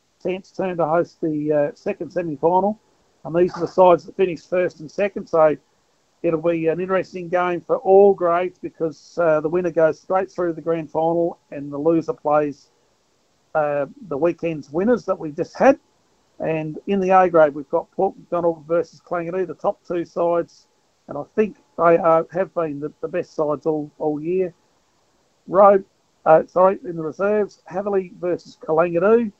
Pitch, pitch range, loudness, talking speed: 170 Hz, 160-185 Hz, -20 LUFS, 175 wpm